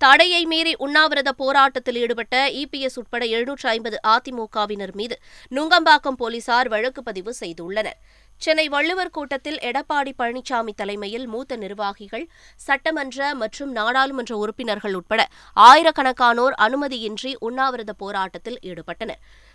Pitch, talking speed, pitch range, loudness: 245 Hz, 105 wpm, 220-275 Hz, -20 LUFS